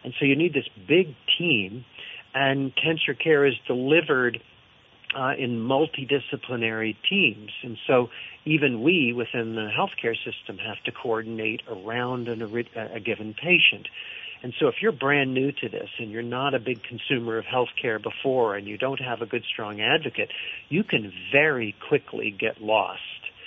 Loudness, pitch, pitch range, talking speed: -25 LUFS, 125 Hz, 115-140 Hz, 165 wpm